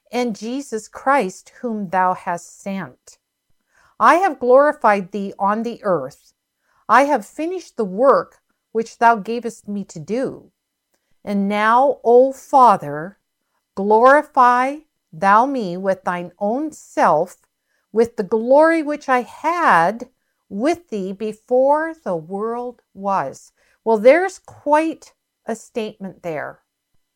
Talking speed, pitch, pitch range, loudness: 120 wpm, 230 Hz, 200-265 Hz, -18 LUFS